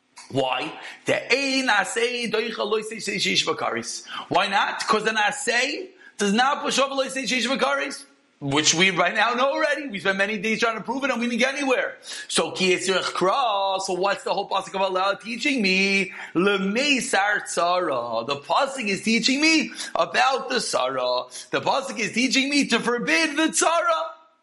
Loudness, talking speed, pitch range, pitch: -22 LUFS, 165 wpm, 195-270 Hz, 230 Hz